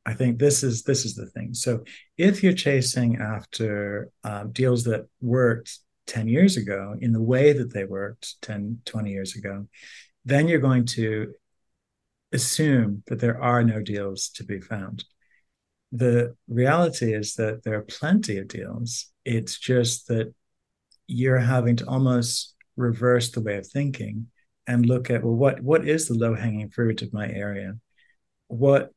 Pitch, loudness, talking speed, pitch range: 120 Hz, -24 LUFS, 165 wpm, 105-125 Hz